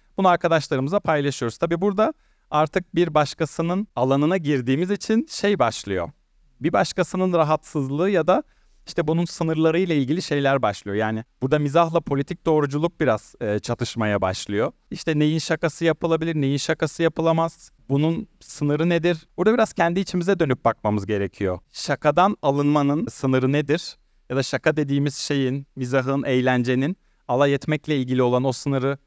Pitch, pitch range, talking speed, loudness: 150 Hz, 135-170 Hz, 140 wpm, -22 LUFS